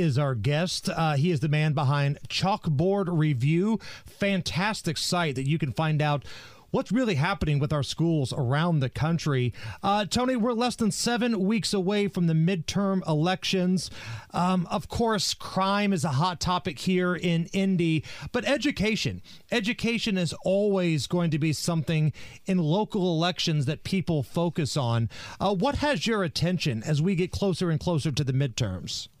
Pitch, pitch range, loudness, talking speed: 170 Hz, 150-195 Hz, -26 LUFS, 165 wpm